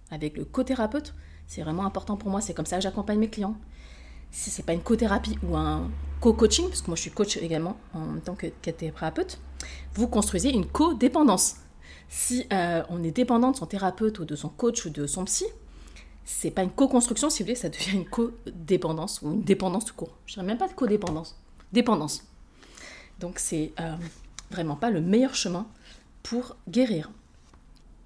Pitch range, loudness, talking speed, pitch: 160-230 Hz, -27 LUFS, 190 wpm, 185 Hz